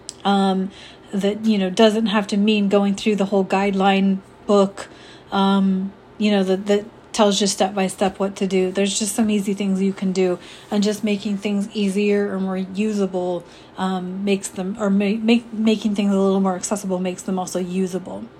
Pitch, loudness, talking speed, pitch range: 200 Hz, -20 LUFS, 190 wpm, 190-205 Hz